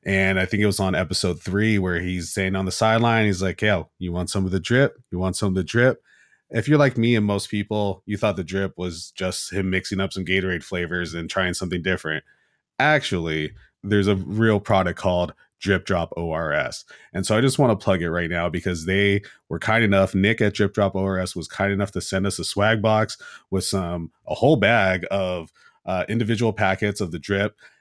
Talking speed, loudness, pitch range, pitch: 220 wpm, -22 LUFS, 90-105 Hz, 95 Hz